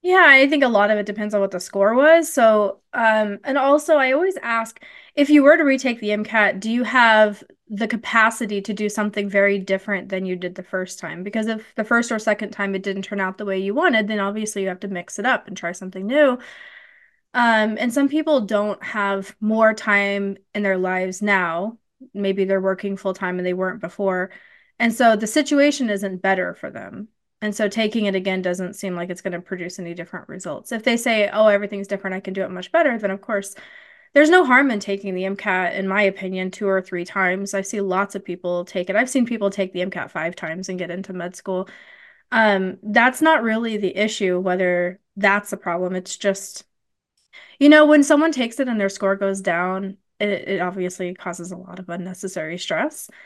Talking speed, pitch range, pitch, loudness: 220 wpm, 190-230 Hz, 200 Hz, -20 LUFS